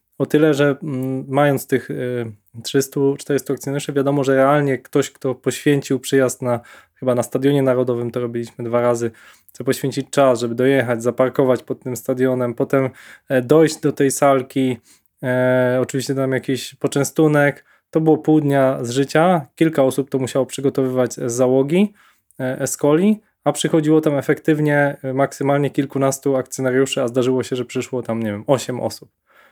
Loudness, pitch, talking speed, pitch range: -19 LUFS, 135 Hz, 150 wpm, 125-140 Hz